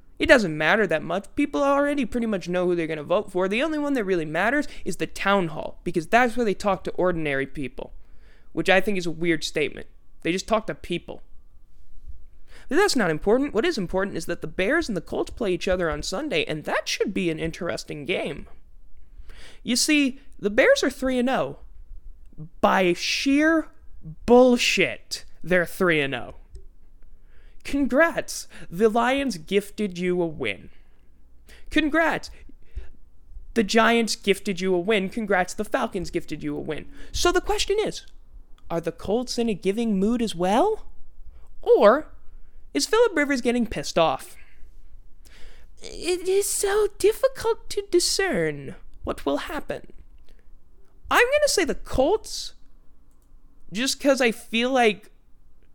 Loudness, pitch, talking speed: -23 LUFS, 195 Hz, 155 wpm